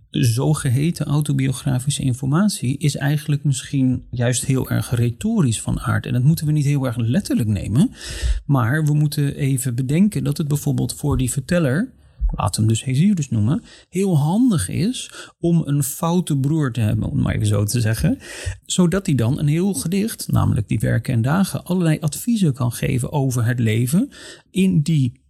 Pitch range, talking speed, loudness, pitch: 125-165 Hz, 175 wpm, -20 LUFS, 140 Hz